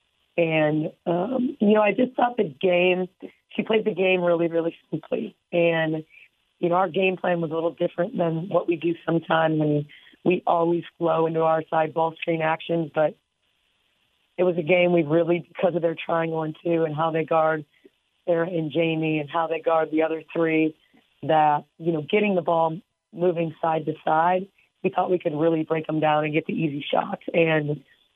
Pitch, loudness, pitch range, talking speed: 165 Hz, -24 LUFS, 160-175 Hz, 195 wpm